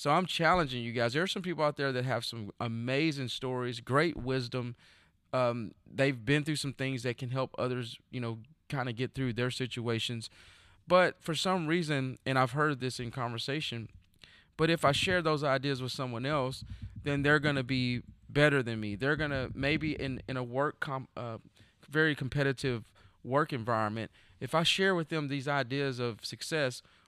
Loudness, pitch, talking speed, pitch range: -32 LUFS, 130 Hz, 190 wpm, 120-145 Hz